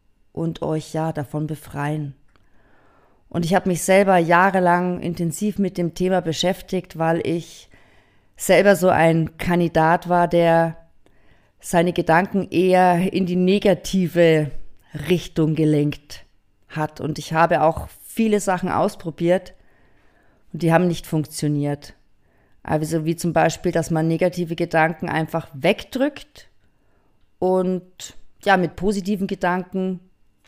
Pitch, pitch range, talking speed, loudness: 170 Hz, 155-185 Hz, 120 wpm, -20 LUFS